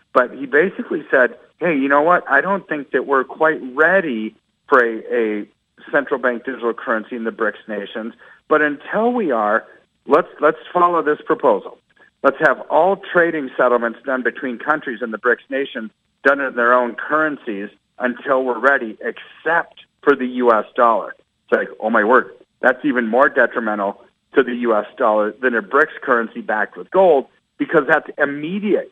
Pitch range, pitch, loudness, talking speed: 115-155 Hz, 130 Hz, -18 LUFS, 170 wpm